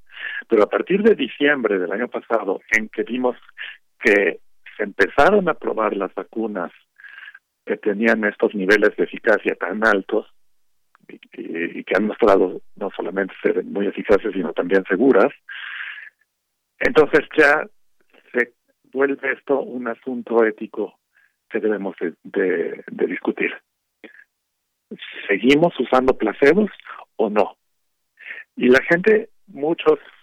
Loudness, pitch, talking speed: -20 LUFS, 170 Hz, 125 wpm